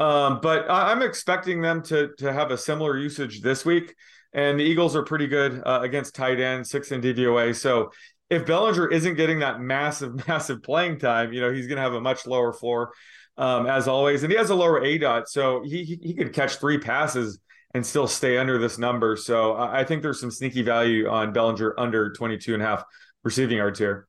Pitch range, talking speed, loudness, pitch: 120-155 Hz, 215 wpm, -24 LUFS, 135 Hz